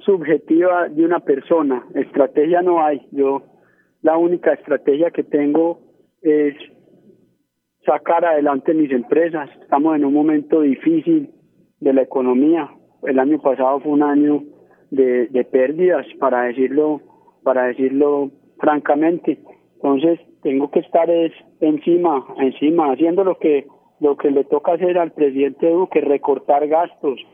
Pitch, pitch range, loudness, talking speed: 150 Hz, 140-170 Hz, -17 LUFS, 130 wpm